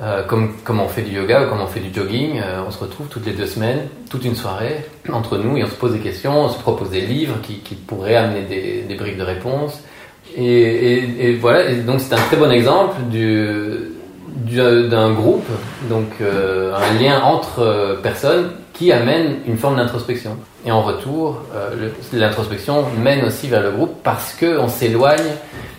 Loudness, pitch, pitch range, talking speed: -17 LUFS, 120 Hz, 105-135 Hz, 200 wpm